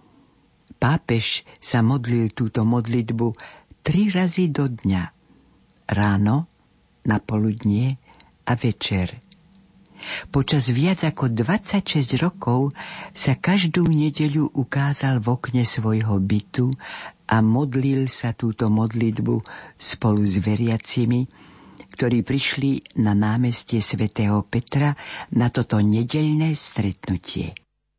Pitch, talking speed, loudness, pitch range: 125 Hz, 95 wpm, -22 LUFS, 110-145 Hz